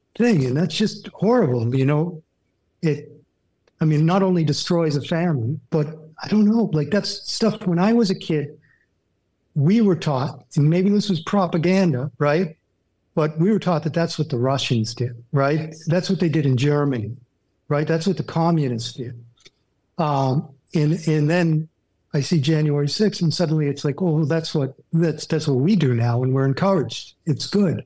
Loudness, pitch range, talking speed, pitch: -21 LUFS, 135-175 Hz, 185 wpm, 155 Hz